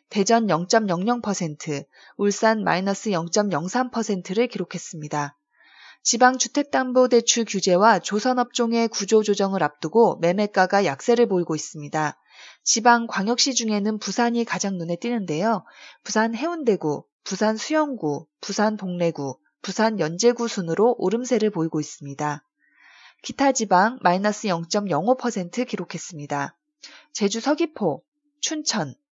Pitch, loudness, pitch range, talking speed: 210 Hz, -22 LUFS, 175-240 Hz, 245 characters per minute